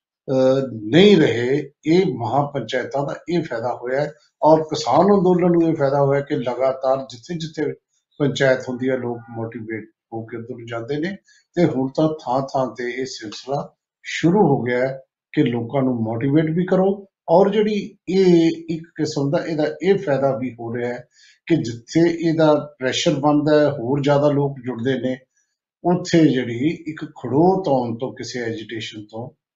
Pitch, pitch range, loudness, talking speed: 140 Hz, 125-165 Hz, -20 LUFS, 160 wpm